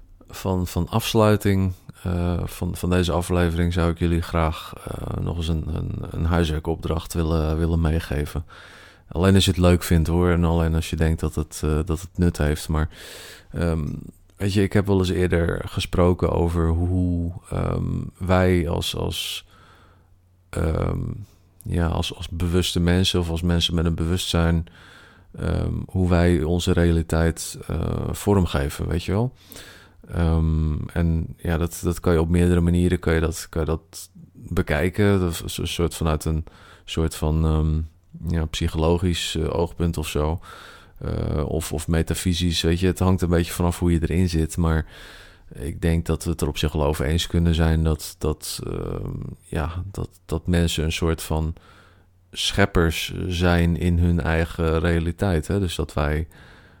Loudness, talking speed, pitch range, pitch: -23 LUFS, 170 wpm, 80-90 Hz, 85 Hz